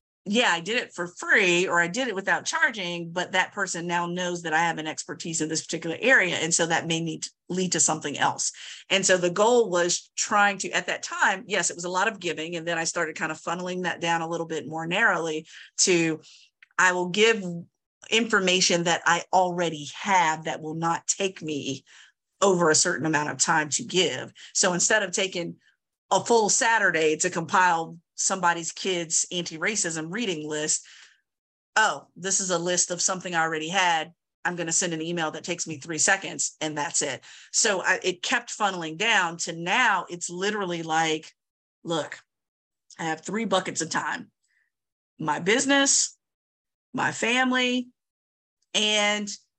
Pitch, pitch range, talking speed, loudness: 175 Hz, 160-195 Hz, 180 wpm, -24 LUFS